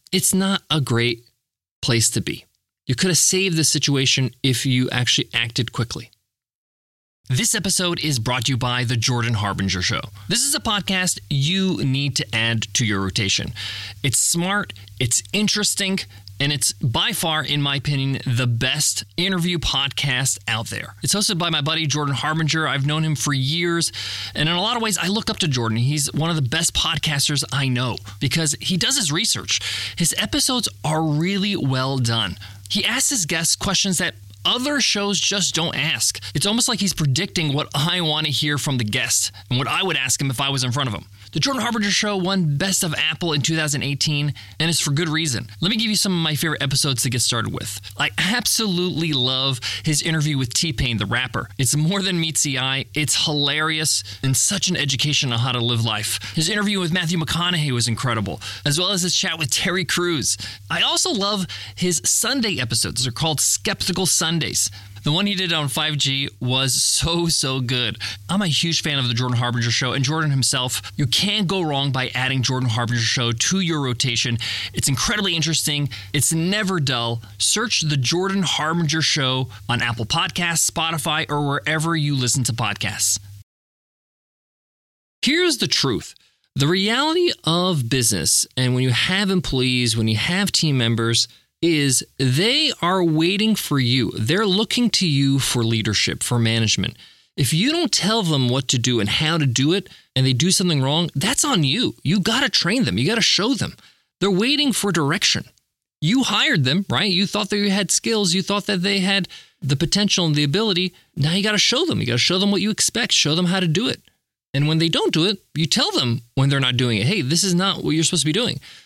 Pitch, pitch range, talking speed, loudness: 145 Hz, 125-180 Hz, 200 wpm, -19 LUFS